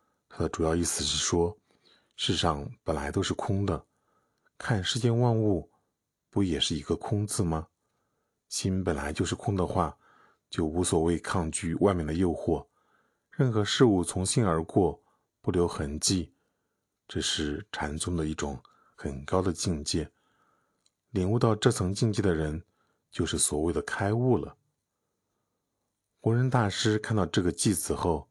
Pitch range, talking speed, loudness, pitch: 80-105 Hz, 210 characters per minute, -28 LUFS, 90 Hz